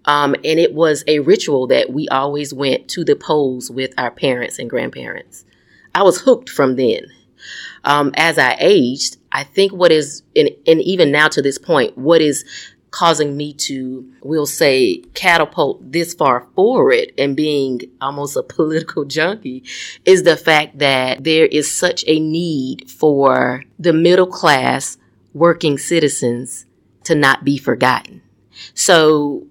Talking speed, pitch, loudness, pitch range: 155 wpm, 150 Hz, -15 LUFS, 135-165 Hz